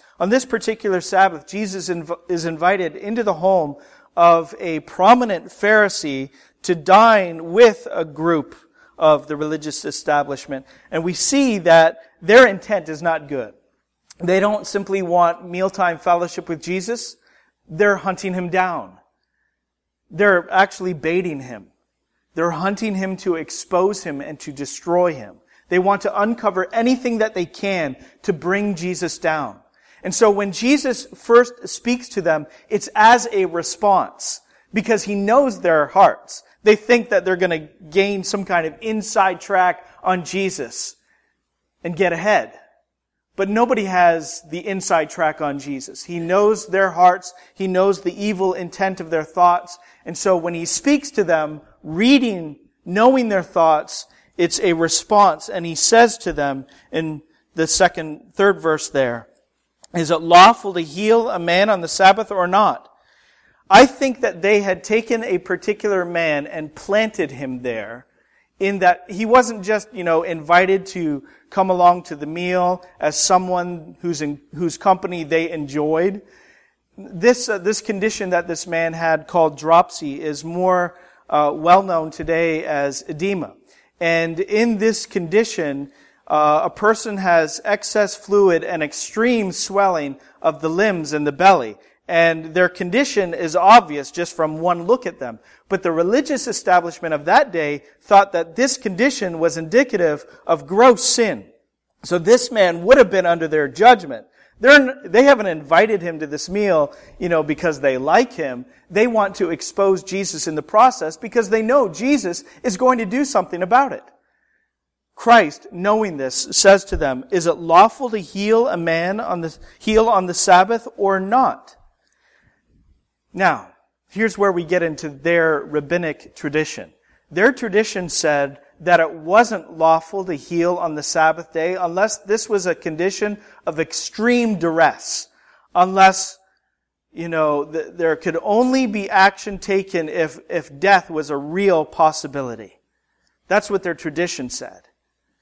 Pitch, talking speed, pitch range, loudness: 180 Hz, 155 wpm, 165-210 Hz, -18 LUFS